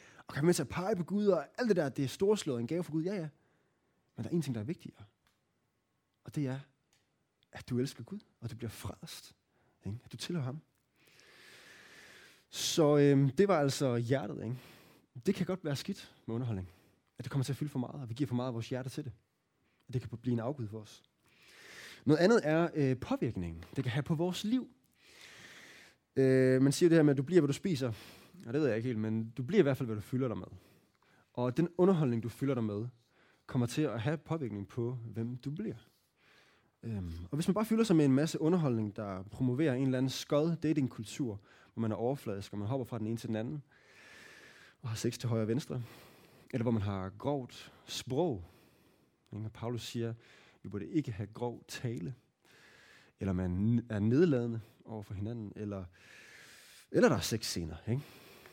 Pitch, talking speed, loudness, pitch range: 125 Hz, 220 wpm, -34 LUFS, 110-150 Hz